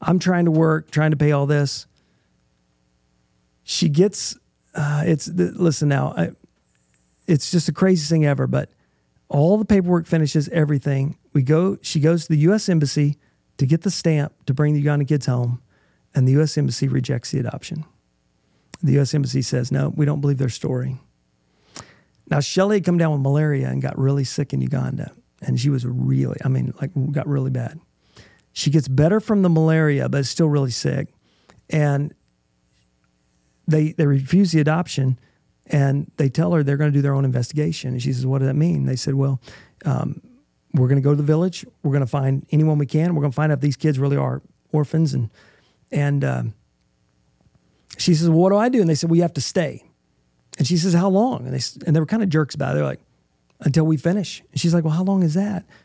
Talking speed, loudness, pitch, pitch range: 210 wpm, -20 LUFS, 145 Hz, 130-160 Hz